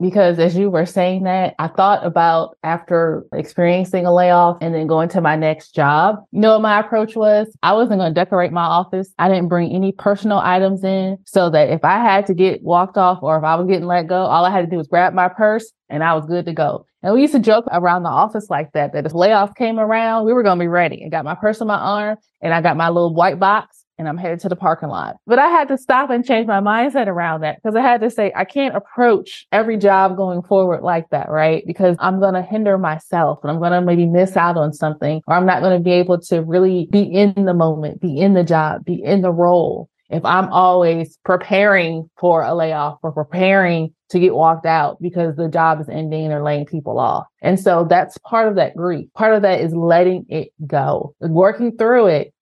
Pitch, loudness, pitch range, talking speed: 180 Hz, -16 LUFS, 165-200 Hz, 245 wpm